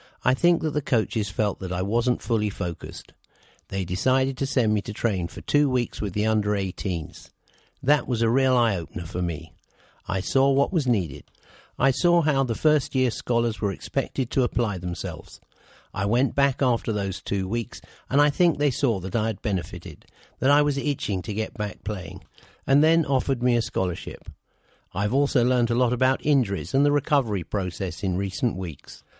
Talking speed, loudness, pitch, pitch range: 195 wpm, -25 LUFS, 115 Hz, 95-135 Hz